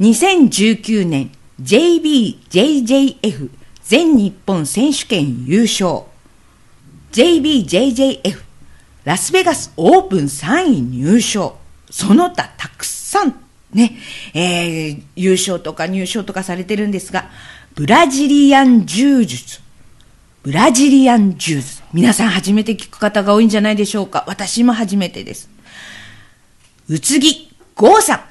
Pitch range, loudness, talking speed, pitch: 180-270 Hz, -14 LUFS, 235 characters per minute, 215 Hz